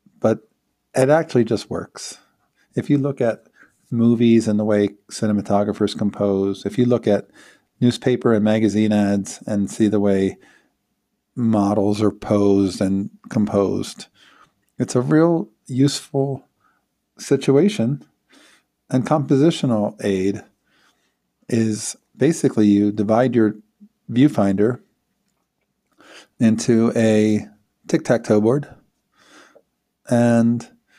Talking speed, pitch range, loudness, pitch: 100 wpm, 105-125 Hz, -19 LUFS, 110 Hz